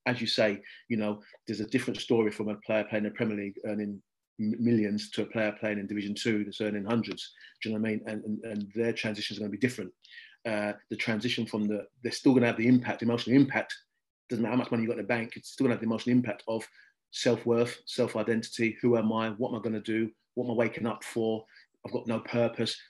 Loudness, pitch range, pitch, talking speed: -30 LUFS, 105-120 Hz, 110 Hz, 250 wpm